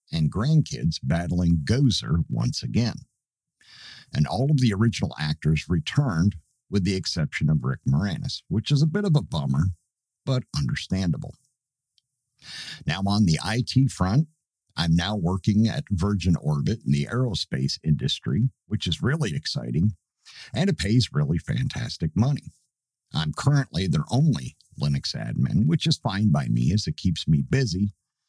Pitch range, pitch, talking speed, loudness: 85-135 Hz, 110 Hz, 145 wpm, -25 LUFS